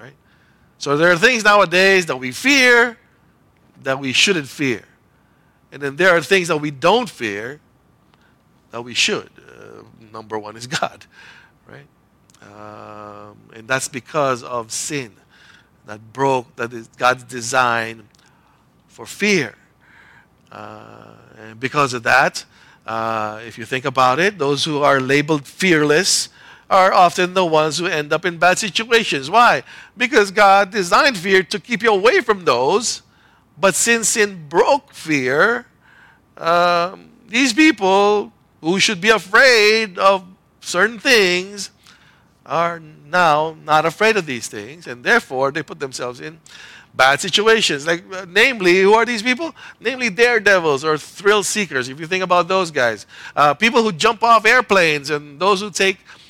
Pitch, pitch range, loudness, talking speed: 175 Hz, 130-205 Hz, -16 LUFS, 150 wpm